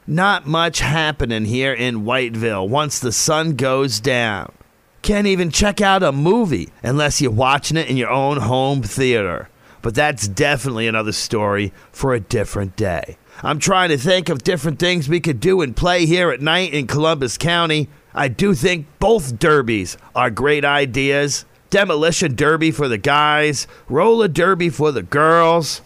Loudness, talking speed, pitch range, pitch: -17 LUFS, 165 wpm, 125-170 Hz, 150 Hz